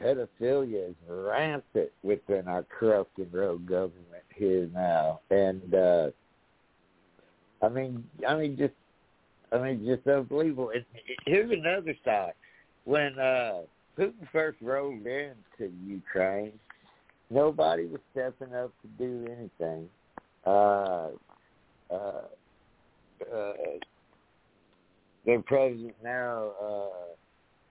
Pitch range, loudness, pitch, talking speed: 95-140 Hz, -30 LUFS, 120 Hz, 105 wpm